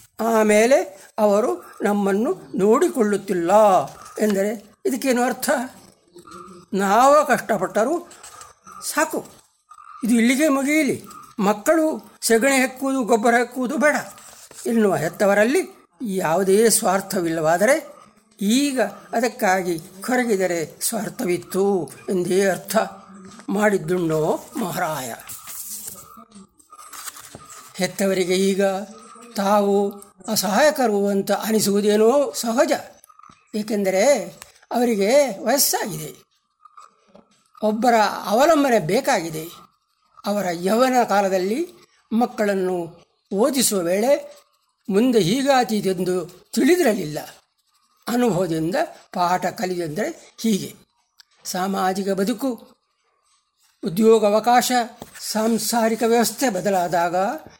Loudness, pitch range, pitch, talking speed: -20 LUFS, 195-265 Hz, 220 Hz, 65 wpm